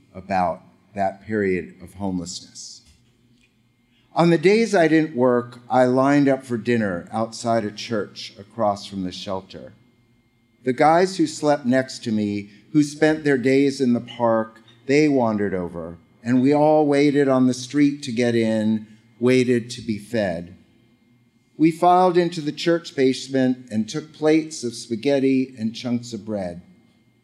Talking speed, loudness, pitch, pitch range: 150 wpm, -21 LUFS, 120 Hz, 110-140 Hz